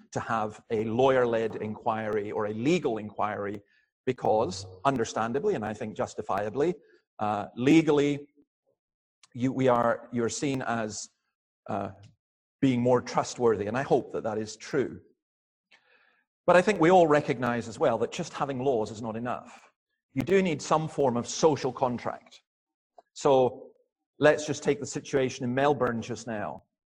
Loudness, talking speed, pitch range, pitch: -28 LUFS, 145 wpm, 110-150 Hz, 125 Hz